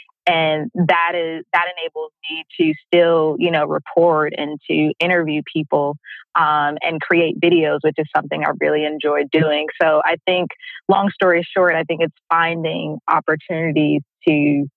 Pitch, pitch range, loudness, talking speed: 160 Hz, 150-175 Hz, -18 LUFS, 155 wpm